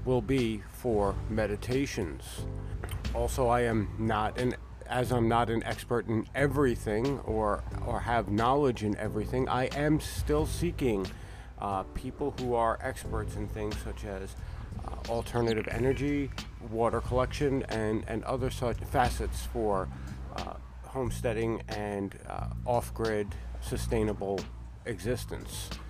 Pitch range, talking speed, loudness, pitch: 100-120 Hz, 125 wpm, -32 LUFS, 110 Hz